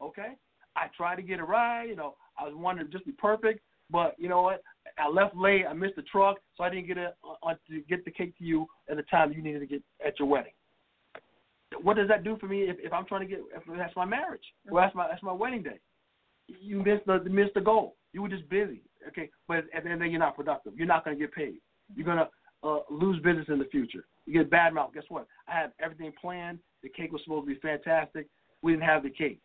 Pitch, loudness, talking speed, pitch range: 175 Hz, -30 LUFS, 255 wpm, 155-195 Hz